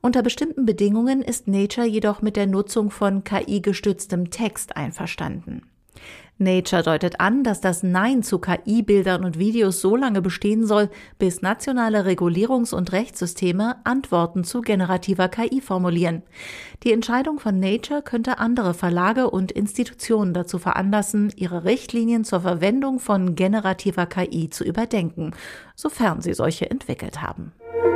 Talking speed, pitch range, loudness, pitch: 135 wpm, 185-230 Hz, -22 LUFS, 205 Hz